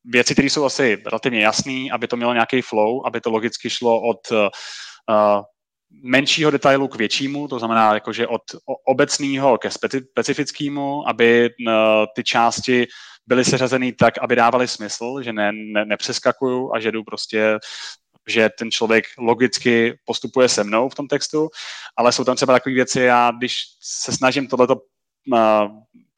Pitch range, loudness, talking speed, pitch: 115-130 Hz, -18 LUFS, 155 wpm, 120 Hz